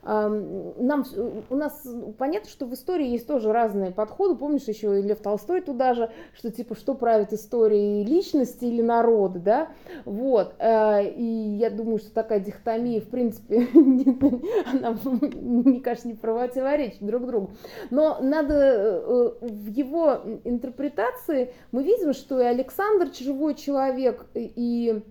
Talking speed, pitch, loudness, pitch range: 135 wpm, 245 Hz, -24 LUFS, 225-285 Hz